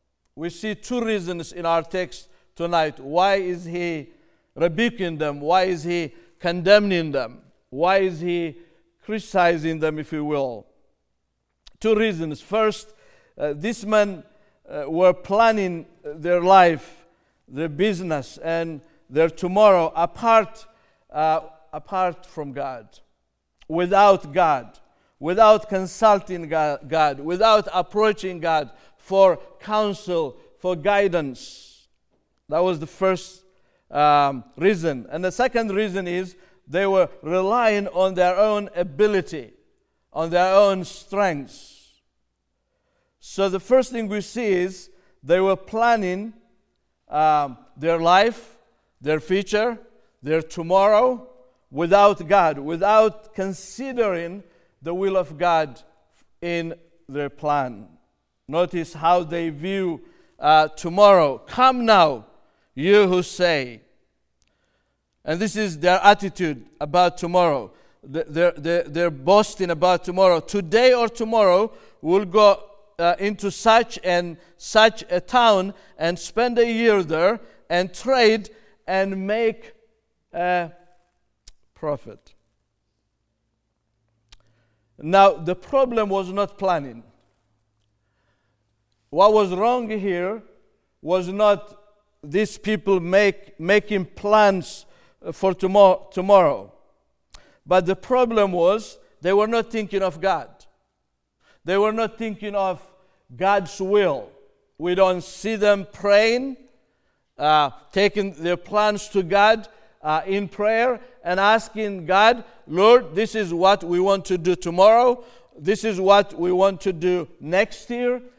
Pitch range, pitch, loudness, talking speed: 165-210 Hz, 185 Hz, -20 LUFS, 115 wpm